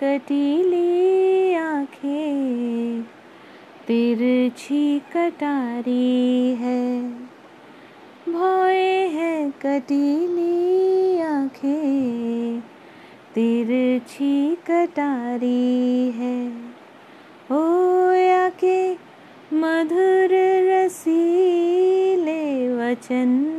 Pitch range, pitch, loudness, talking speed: 250-350 Hz, 290 Hz, -20 LUFS, 45 wpm